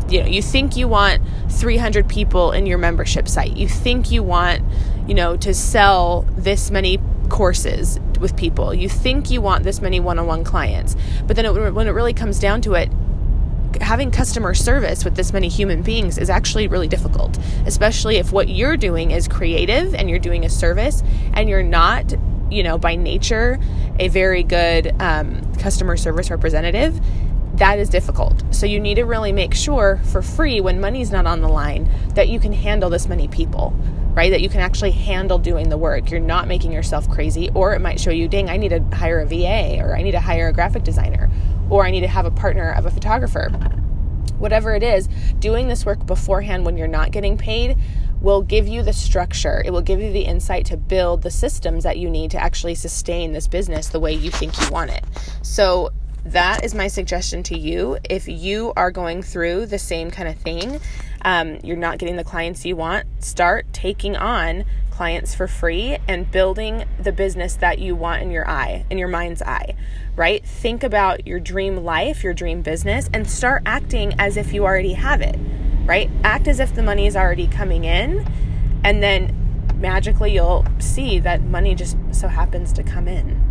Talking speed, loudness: 200 wpm, -19 LUFS